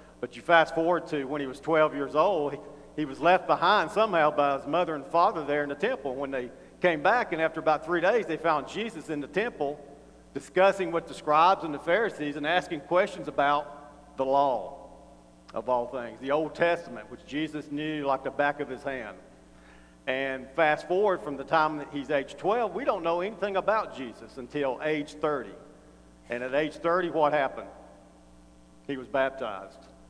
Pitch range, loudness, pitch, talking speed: 135-165 Hz, -27 LUFS, 145 Hz, 195 wpm